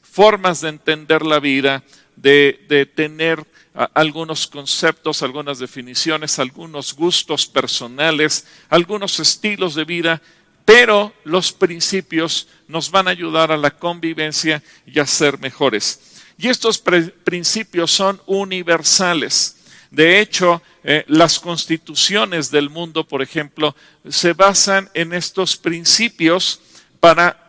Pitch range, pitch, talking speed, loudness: 150-180 Hz, 165 Hz, 120 wpm, -15 LUFS